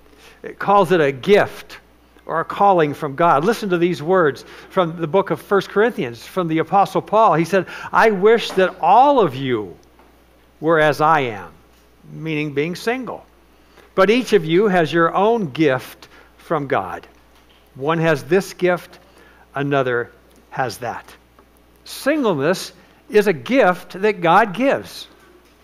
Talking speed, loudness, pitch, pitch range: 145 wpm, -18 LUFS, 170 Hz, 135-200 Hz